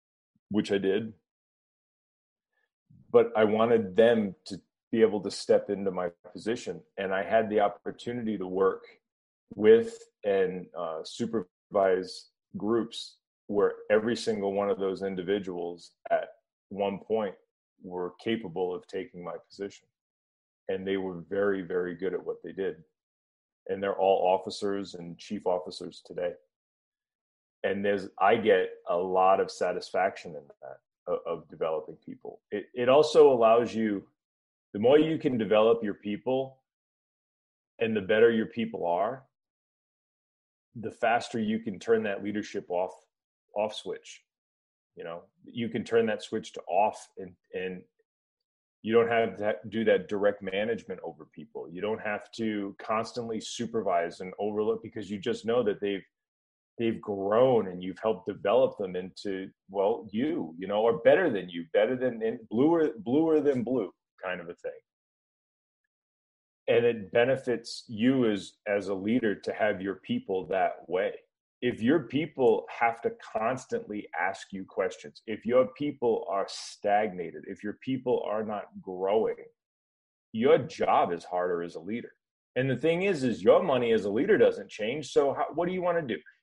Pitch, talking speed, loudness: 110 Hz, 155 wpm, -28 LUFS